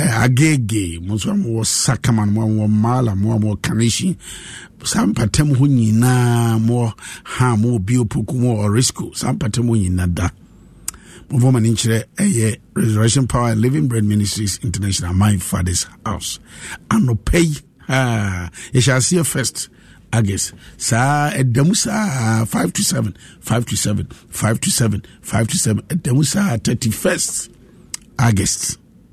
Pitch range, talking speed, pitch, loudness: 105-130 Hz, 140 wpm, 115 Hz, -17 LUFS